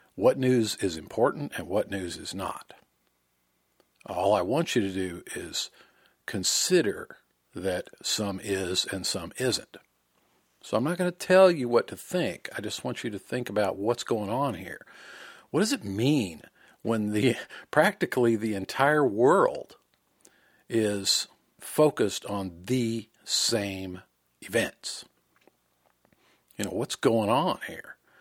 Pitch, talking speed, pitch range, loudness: 105 Hz, 140 wpm, 90-125 Hz, -27 LUFS